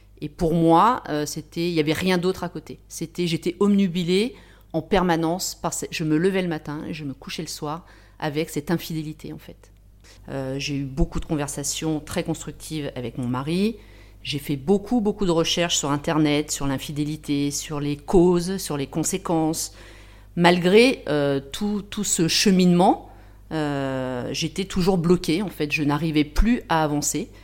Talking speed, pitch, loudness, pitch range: 170 wpm, 160 Hz, -23 LUFS, 145-180 Hz